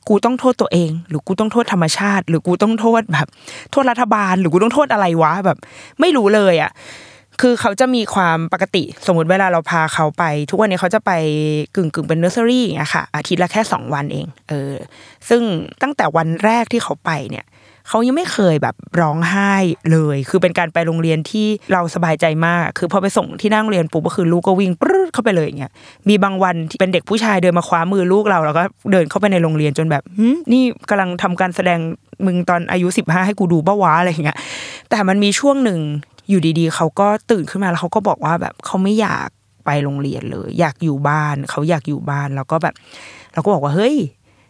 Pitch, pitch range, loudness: 180 Hz, 160-205 Hz, -16 LUFS